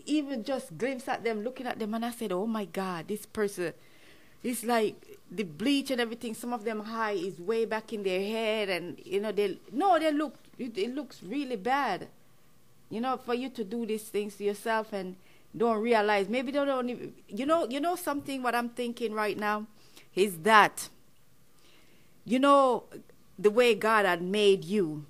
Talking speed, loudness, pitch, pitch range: 195 wpm, -29 LUFS, 225 Hz, 205-255 Hz